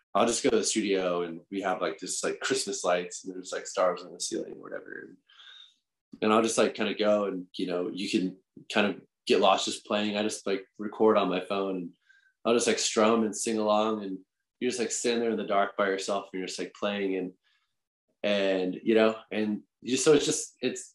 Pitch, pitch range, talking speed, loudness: 105 Hz, 95-110 Hz, 240 wpm, -28 LUFS